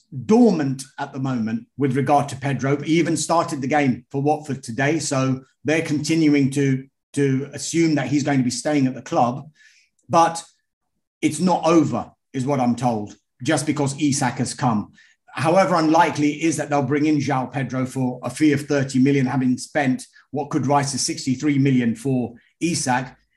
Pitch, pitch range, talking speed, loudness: 140 Hz, 130-150 Hz, 175 wpm, -21 LUFS